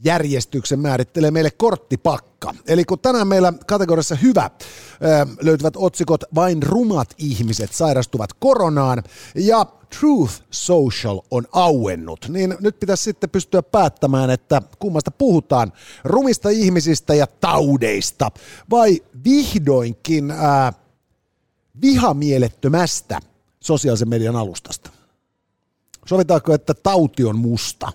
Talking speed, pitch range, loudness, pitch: 100 wpm, 130-185 Hz, -18 LUFS, 155 Hz